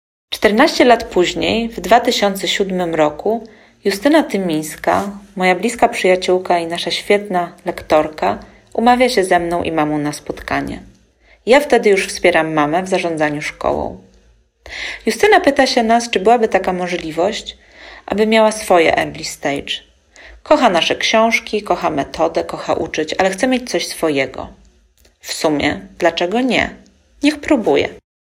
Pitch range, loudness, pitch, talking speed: 170-230 Hz, -16 LUFS, 190 Hz, 130 wpm